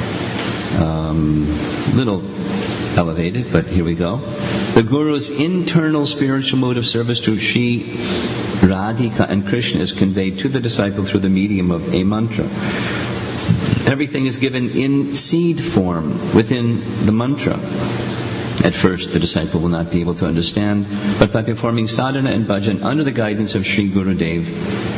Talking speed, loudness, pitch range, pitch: 150 wpm, -17 LUFS, 95-125 Hz, 110 Hz